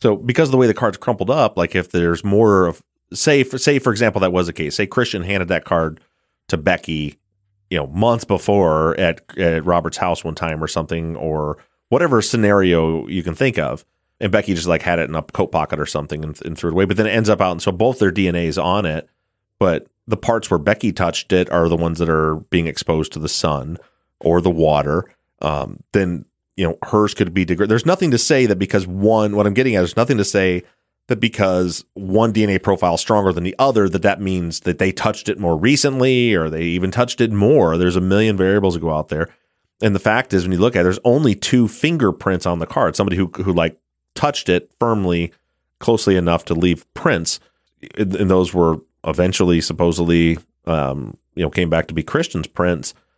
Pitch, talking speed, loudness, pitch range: 90 Hz, 225 wpm, -18 LUFS, 85-105 Hz